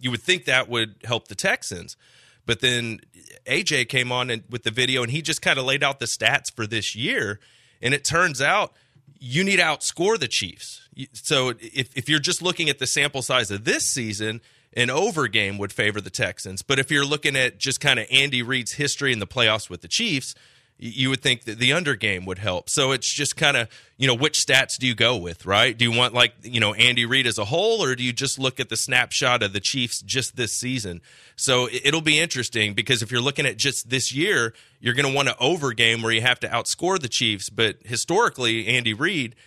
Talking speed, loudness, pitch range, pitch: 235 wpm, -21 LUFS, 115-140 Hz, 125 Hz